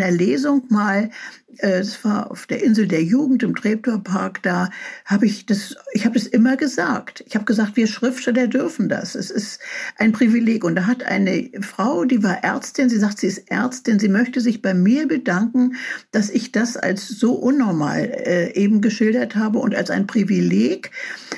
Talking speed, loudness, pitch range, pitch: 175 wpm, -19 LUFS, 200-250 Hz, 225 Hz